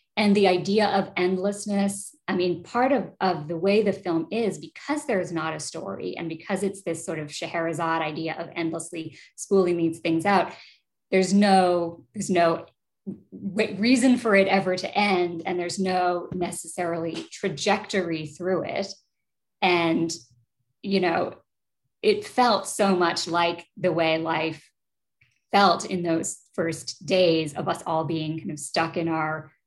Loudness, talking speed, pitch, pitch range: -25 LUFS, 155 wpm, 175 Hz, 165-195 Hz